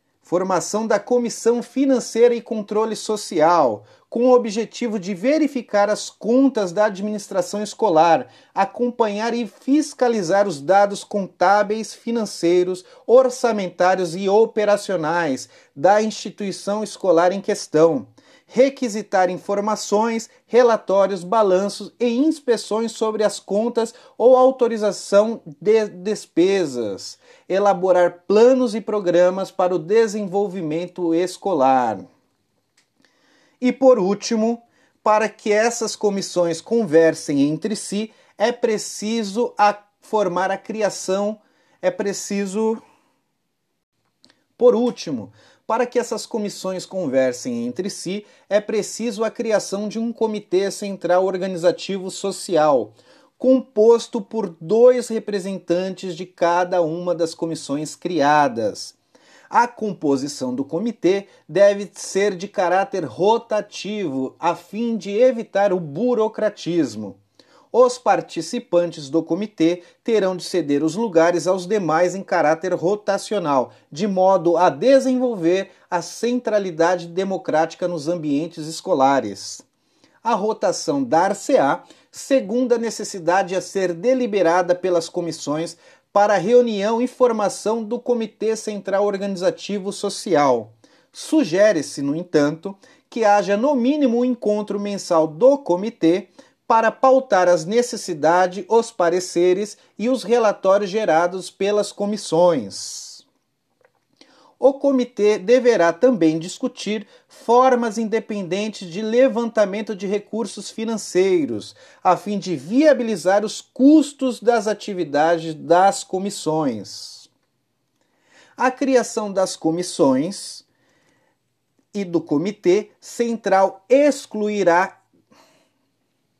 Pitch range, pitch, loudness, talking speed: 180-230 Hz, 205 Hz, -20 LUFS, 100 wpm